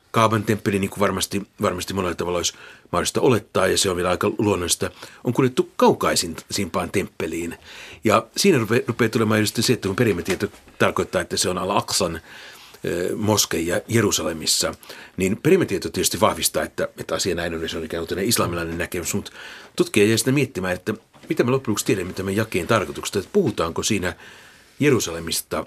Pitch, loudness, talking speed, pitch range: 105 Hz, -22 LUFS, 170 wpm, 90-115 Hz